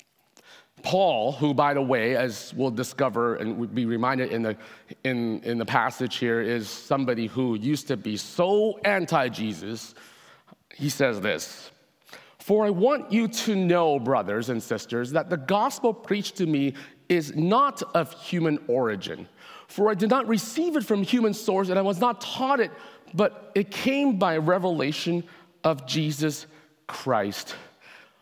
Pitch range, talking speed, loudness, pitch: 130-200 Hz, 155 wpm, -25 LUFS, 155 Hz